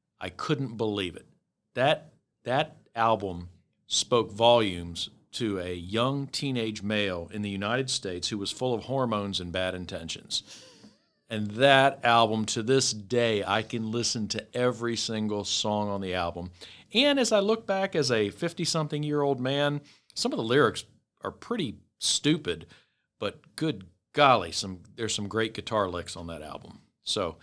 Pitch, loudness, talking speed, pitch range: 110 Hz, -28 LUFS, 160 wpm, 100-135 Hz